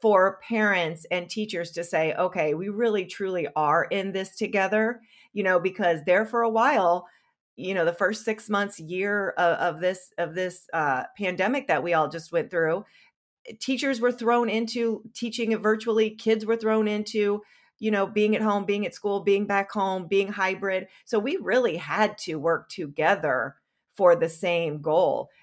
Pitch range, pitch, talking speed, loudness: 180-220 Hz, 200 Hz, 175 wpm, -25 LUFS